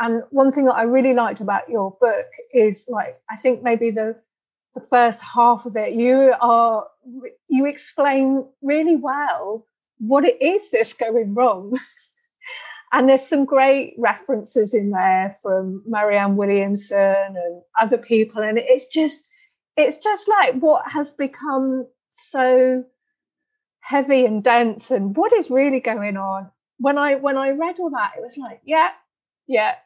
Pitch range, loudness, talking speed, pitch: 225-290 Hz, -19 LUFS, 155 wpm, 255 Hz